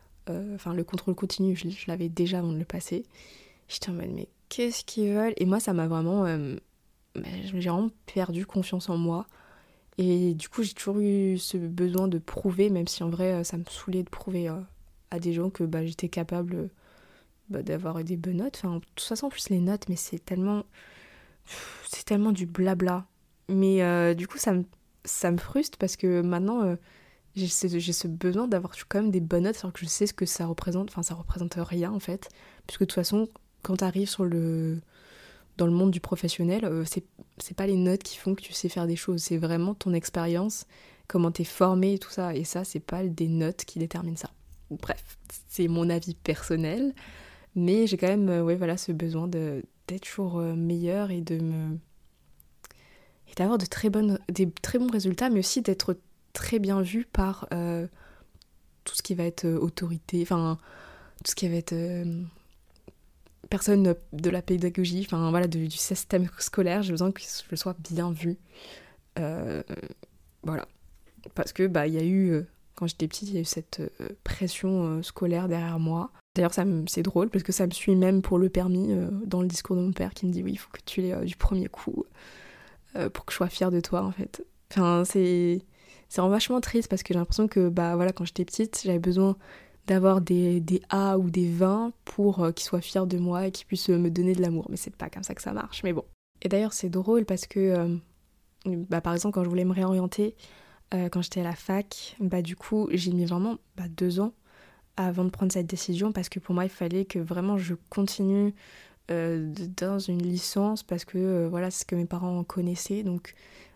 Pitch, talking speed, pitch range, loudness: 180 Hz, 215 wpm, 170-190 Hz, -28 LUFS